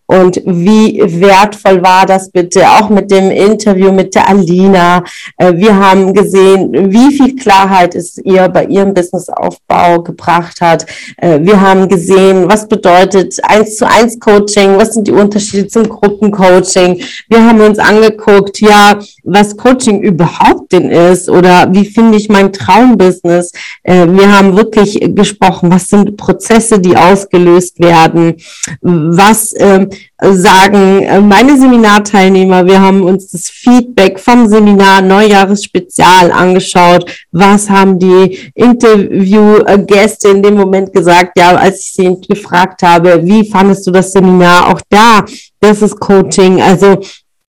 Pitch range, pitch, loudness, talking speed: 185-210 Hz, 195 Hz, -6 LUFS, 135 wpm